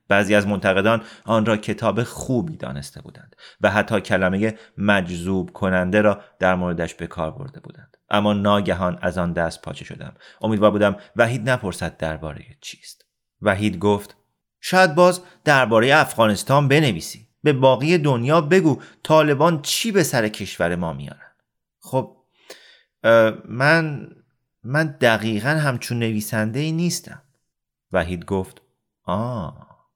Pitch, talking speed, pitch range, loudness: 110 Hz, 125 wpm, 95-140 Hz, -20 LUFS